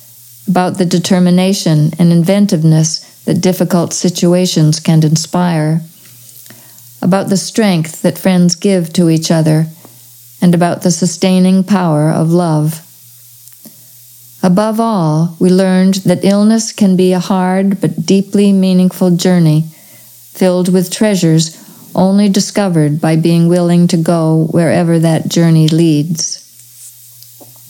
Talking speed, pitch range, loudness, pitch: 115 wpm, 155-185 Hz, -11 LUFS, 175 Hz